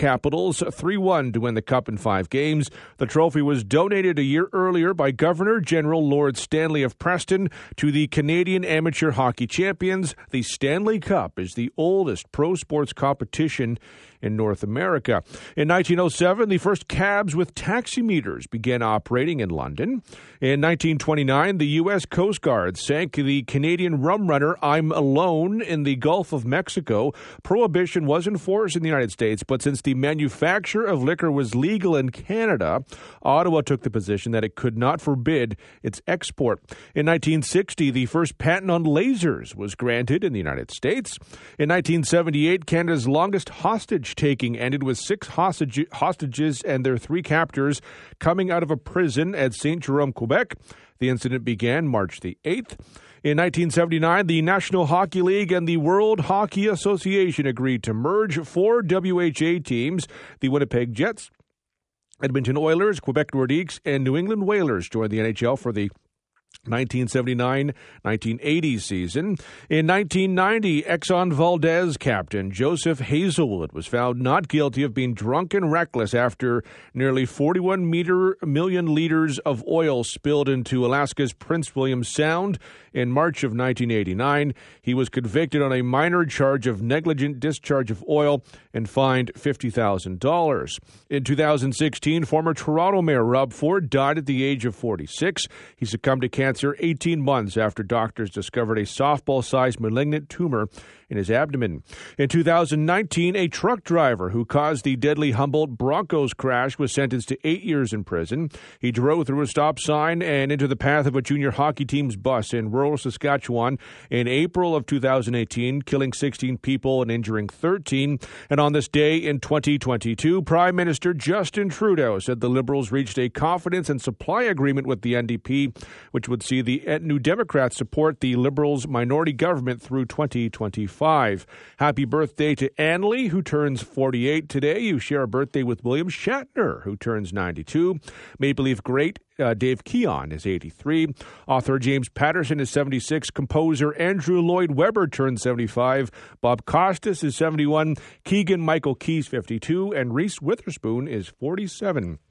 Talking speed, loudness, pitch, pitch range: 155 wpm, -23 LUFS, 145 Hz, 125-165 Hz